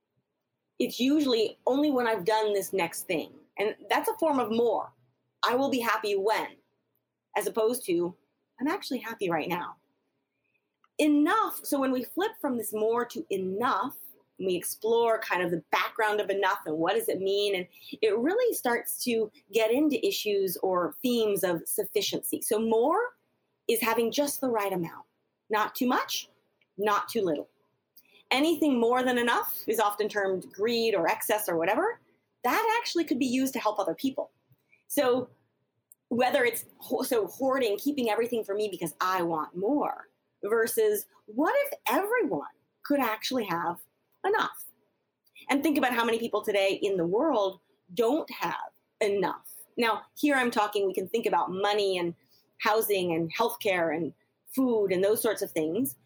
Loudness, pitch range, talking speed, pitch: -28 LUFS, 200-285 Hz, 165 wpm, 230 Hz